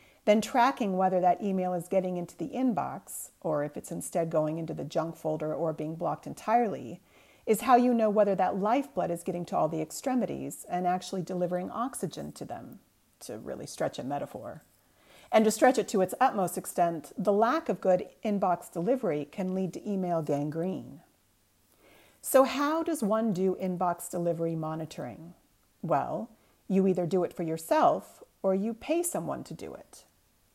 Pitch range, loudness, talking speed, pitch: 170-220 Hz, -29 LUFS, 175 wpm, 185 Hz